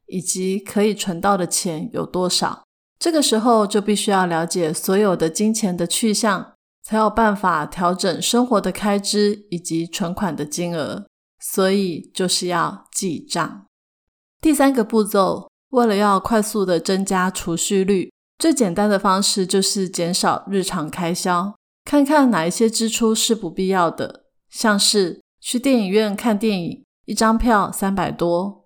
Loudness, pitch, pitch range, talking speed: -19 LUFS, 200 Hz, 180-220 Hz, 230 characters per minute